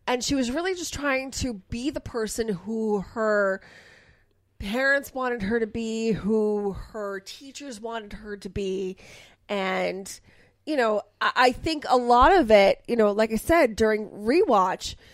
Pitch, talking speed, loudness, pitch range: 225 Hz, 165 wpm, -24 LUFS, 205-255 Hz